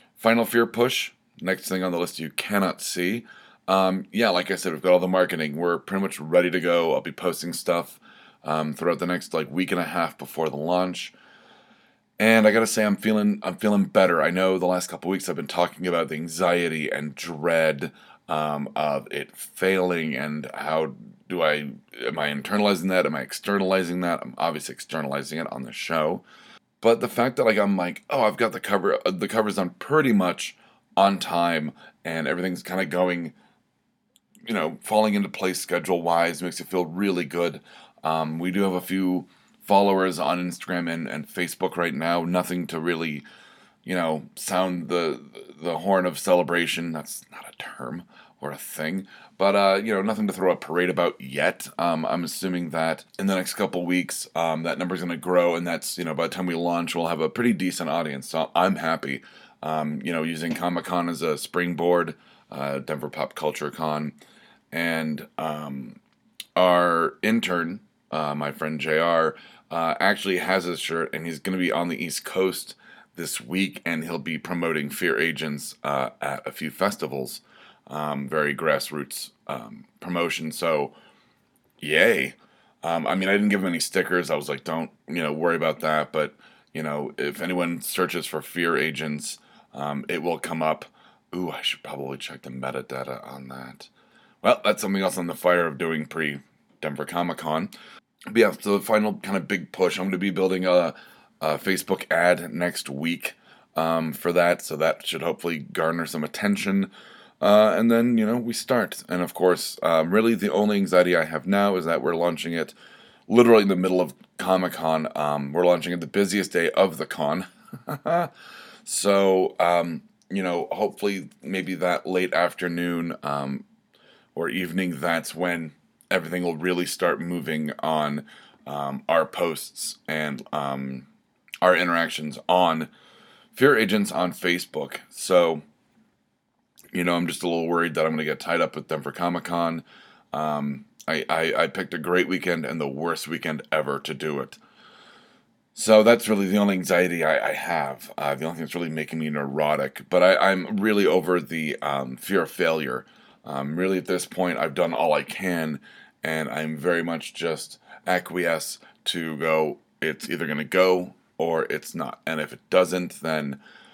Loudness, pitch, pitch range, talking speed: -24 LUFS, 85 Hz, 80-95 Hz, 185 wpm